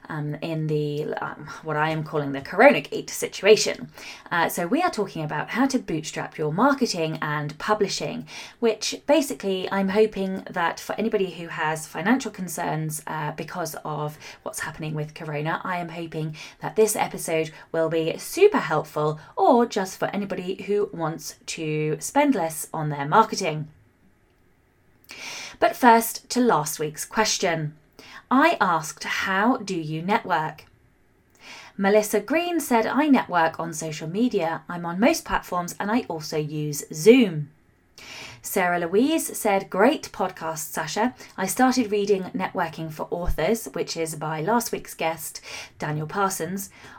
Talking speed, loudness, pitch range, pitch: 145 wpm, -24 LUFS, 155-215 Hz, 170 Hz